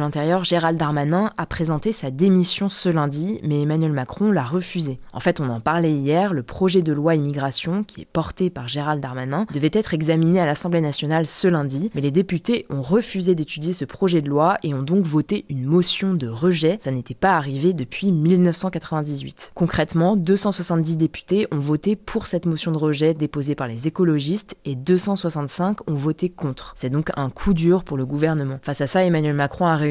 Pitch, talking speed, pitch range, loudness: 165 Hz, 195 wpm, 145-185 Hz, -21 LUFS